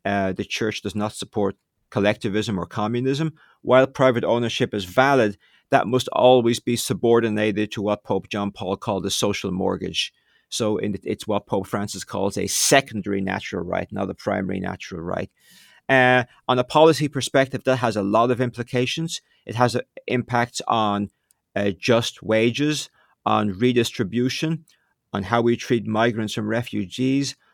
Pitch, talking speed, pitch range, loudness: 115 Hz, 155 wpm, 105-125 Hz, -22 LUFS